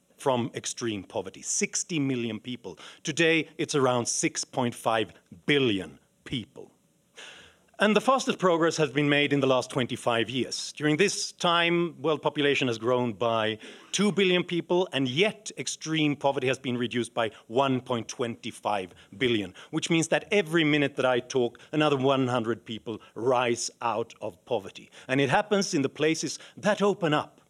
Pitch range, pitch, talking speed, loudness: 125-165 Hz, 140 Hz, 150 wpm, -27 LUFS